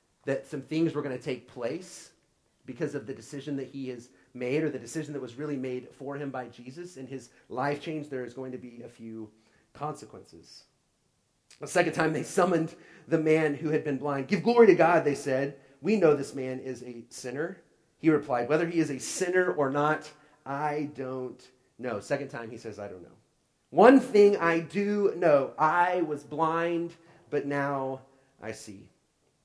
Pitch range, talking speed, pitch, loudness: 130-160 Hz, 190 wpm, 145 Hz, -28 LUFS